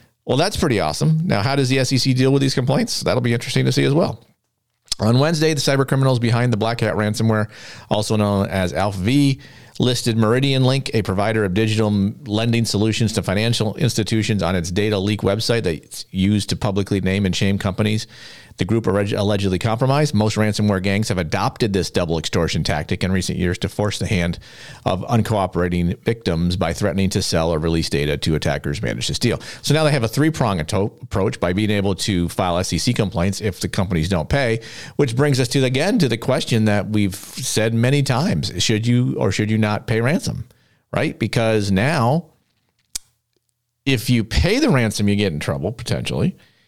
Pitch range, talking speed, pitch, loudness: 95-125 Hz, 190 wpm, 110 Hz, -19 LUFS